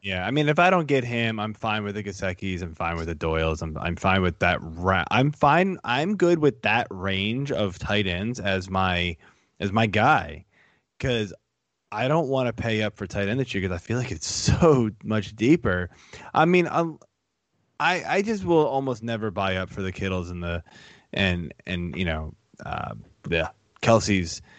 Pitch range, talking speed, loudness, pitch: 90-125 Hz, 200 wpm, -24 LUFS, 100 Hz